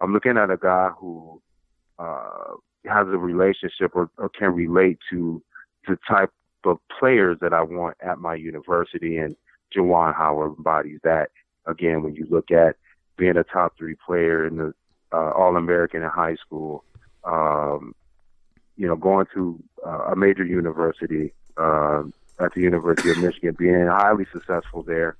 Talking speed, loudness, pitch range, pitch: 155 wpm, -22 LUFS, 80-90 Hz, 85 Hz